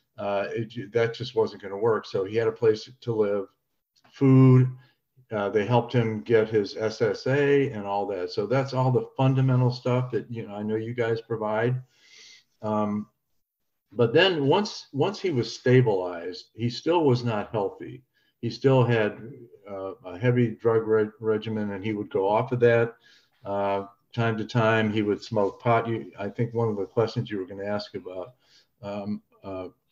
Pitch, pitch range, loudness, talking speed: 115 Hz, 105-125 Hz, -25 LUFS, 185 wpm